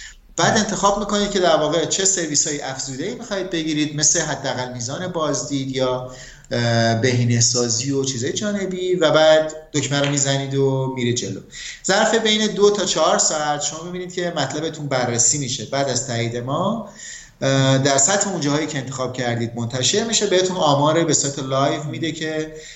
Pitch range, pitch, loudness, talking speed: 135-180 Hz, 150 Hz, -19 LUFS, 165 wpm